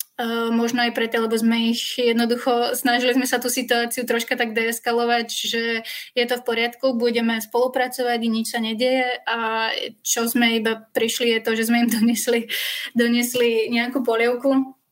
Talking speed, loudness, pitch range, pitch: 165 wpm, -21 LUFS, 230-245 Hz, 235 Hz